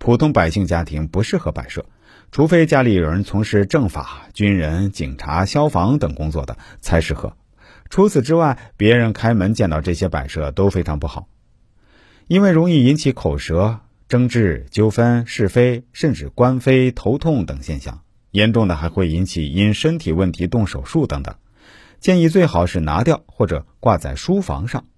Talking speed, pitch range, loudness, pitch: 255 characters per minute, 85-125 Hz, -17 LUFS, 105 Hz